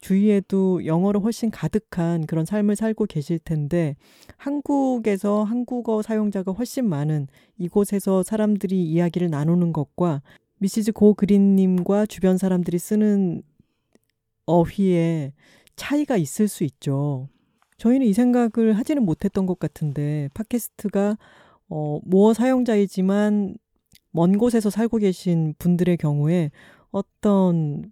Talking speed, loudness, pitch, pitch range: 275 characters per minute, -22 LUFS, 195 Hz, 170-215 Hz